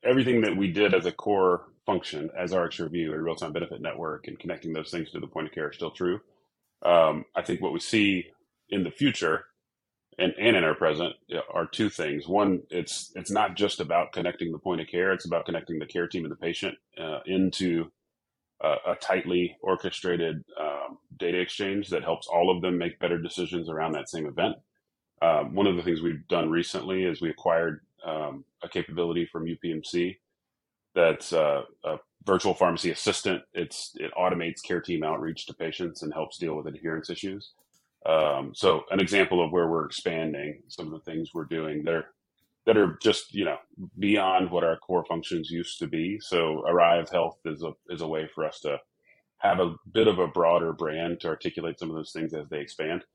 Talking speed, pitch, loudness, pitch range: 200 wpm, 85 Hz, -28 LUFS, 80-90 Hz